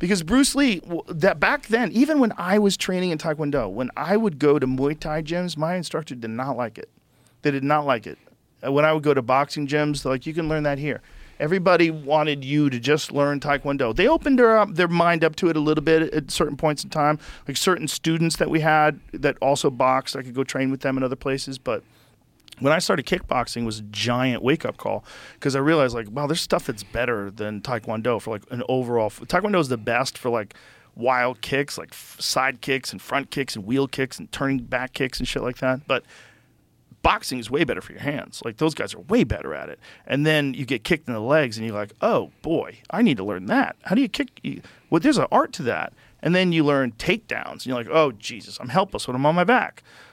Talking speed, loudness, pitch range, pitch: 245 wpm, -23 LUFS, 130-160 Hz, 145 Hz